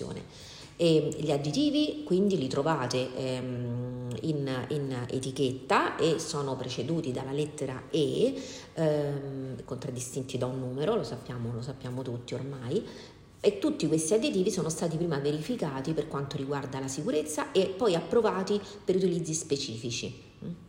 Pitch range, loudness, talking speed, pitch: 130-160 Hz, -30 LUFS, 135 wpm, 140 Hz